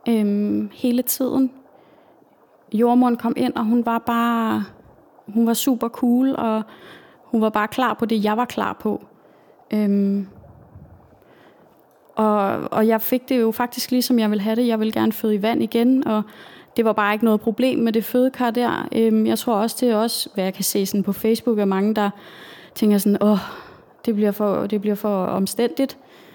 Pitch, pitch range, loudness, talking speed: 225 Hz, 210-245 Hz, -20 LUFS, 190 wpm